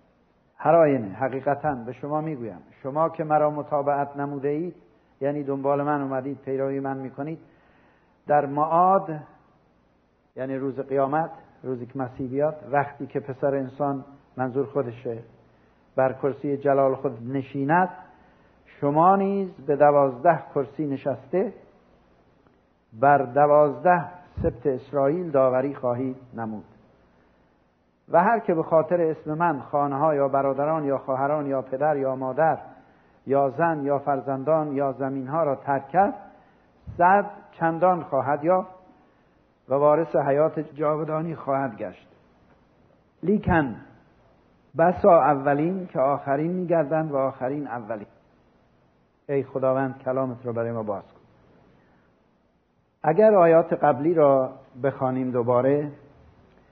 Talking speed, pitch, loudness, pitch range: 115 wpm, 140 Hz, -24 LUFS, 130-155 Hz